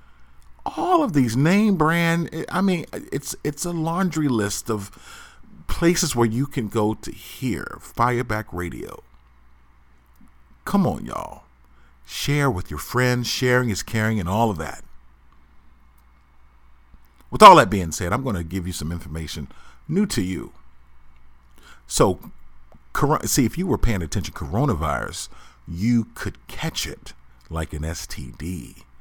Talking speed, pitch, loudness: 130 wpm, 90 Hz, -22 LUFS